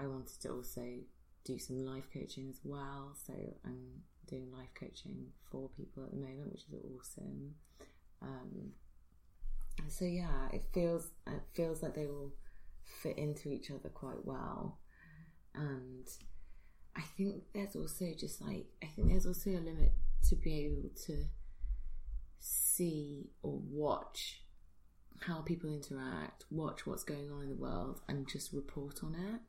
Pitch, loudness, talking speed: 140 Hz, -43 LUFS, 150 wpm